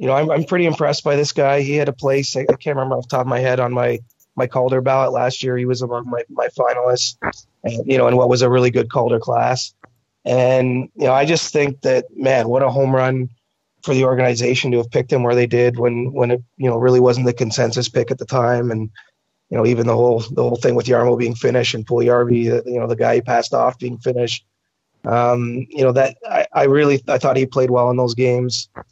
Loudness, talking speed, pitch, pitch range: -17 LUFS, 250 wpm, 125 Hz, 120-130 Hz